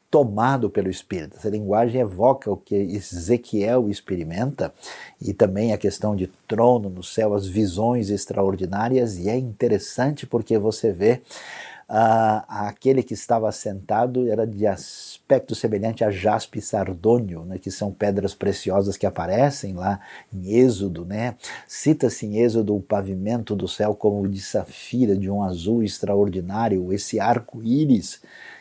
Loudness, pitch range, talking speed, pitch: -22 LUFS, 100-115 Hz, 140 wpm, 105 Hz